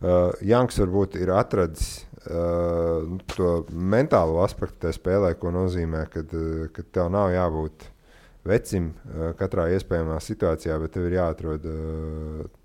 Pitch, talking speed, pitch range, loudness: 85 Hz, 130 wpm, 80-90 Hz, -25 LUFS